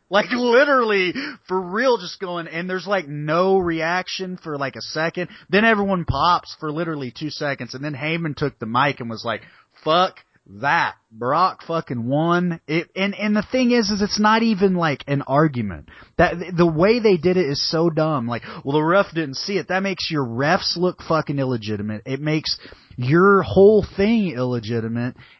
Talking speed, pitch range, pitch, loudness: 185 wpm, 140-195 Hz, 165 Hz, -20 LUFS